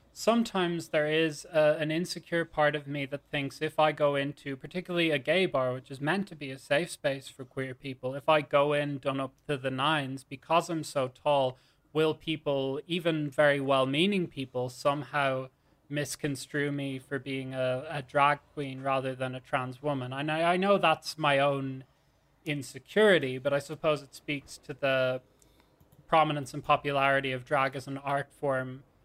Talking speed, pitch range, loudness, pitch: 180 wpm, 135-155 Hz, -30 LUFS, 145 Hz